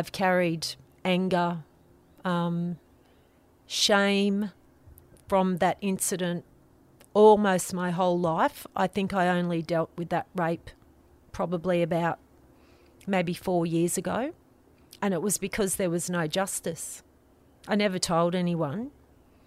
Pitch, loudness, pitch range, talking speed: 175 Hz, -27 LUFS, 165-190 Hz, 115 wpm